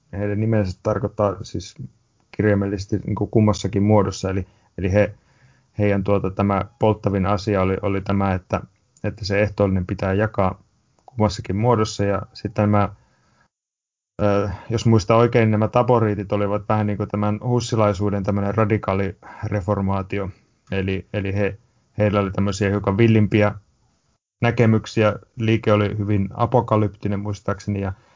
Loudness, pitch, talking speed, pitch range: -21 LUFS, 105 Hz, 130 wpm, 100-110 Hz